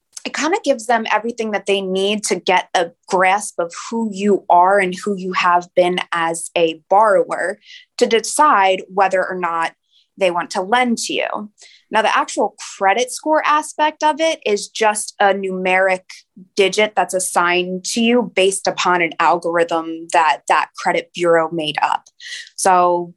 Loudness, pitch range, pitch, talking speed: -17 LUFS, 180-225 Hz, 195 Hz, 165 wpm